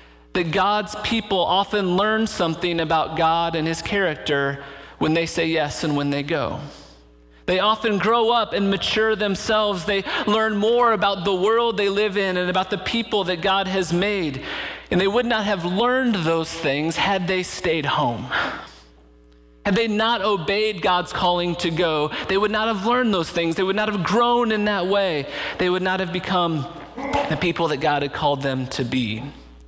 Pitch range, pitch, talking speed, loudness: 155-210 Hz, 185 Hz, 185 wpm, -21 LUFS